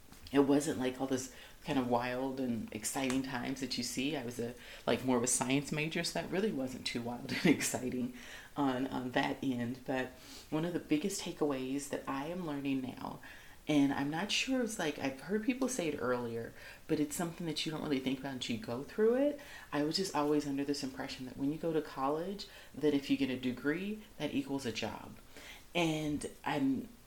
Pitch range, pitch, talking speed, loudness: 130-160 Hz, 140 Hz, 215 wpm, -35 LUFS